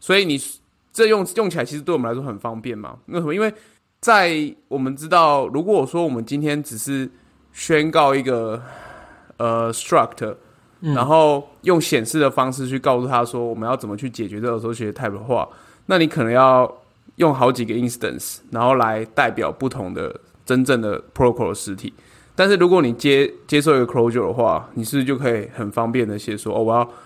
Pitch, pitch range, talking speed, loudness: 130 Hz, 115-150 Hz, 340 characters per minute, -19 LUFS